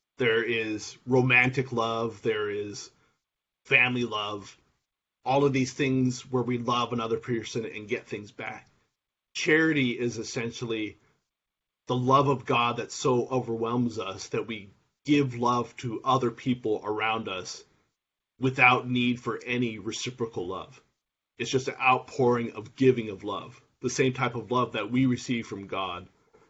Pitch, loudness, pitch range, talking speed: 120 Hz, -27 LUFS, 115-130 Hz, 145 wpm